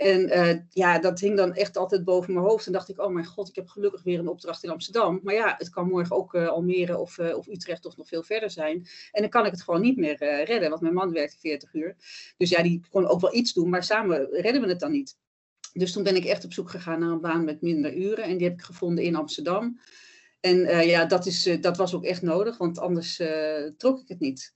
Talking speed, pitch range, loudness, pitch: 275 wpm, 170-195 Hz, -26 LUFS, 180 Hz